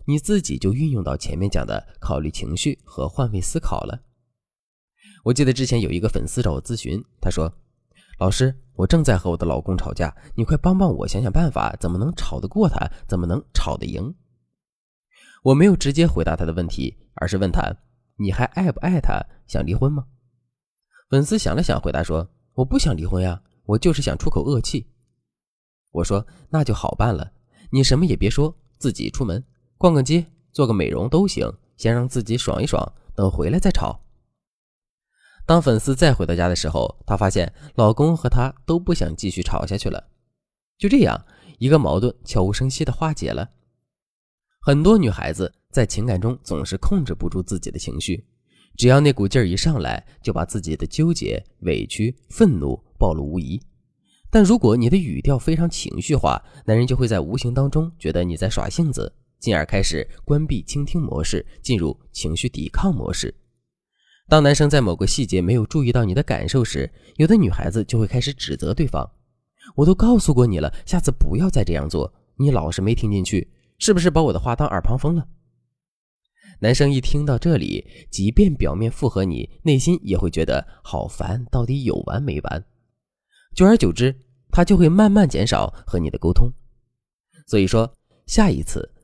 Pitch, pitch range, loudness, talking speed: 120 Hz, 95-145 Hz, -21 LUFS, 270 characters per minute